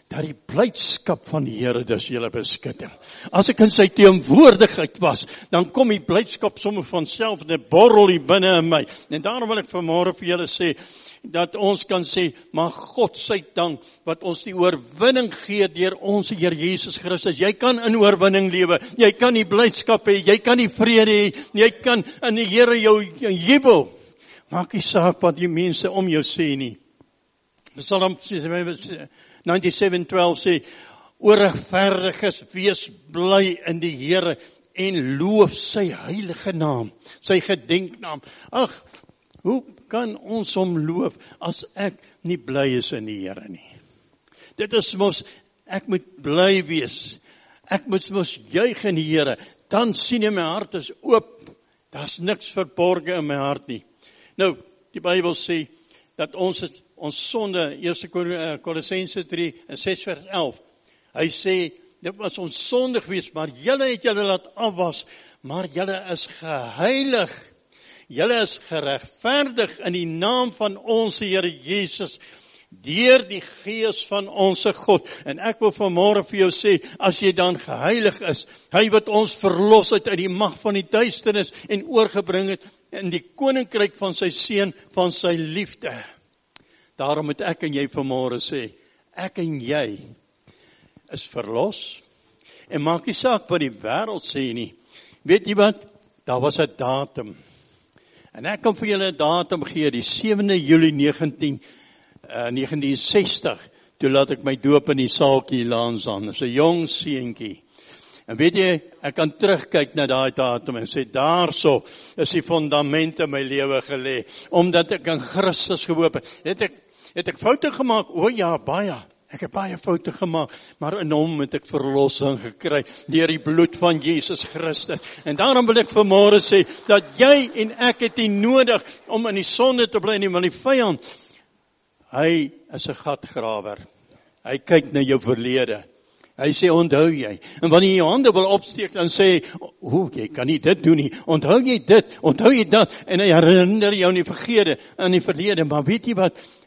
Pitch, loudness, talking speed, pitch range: 180 Hz, -20 LUFS, 165 wpm, 155-205 Hz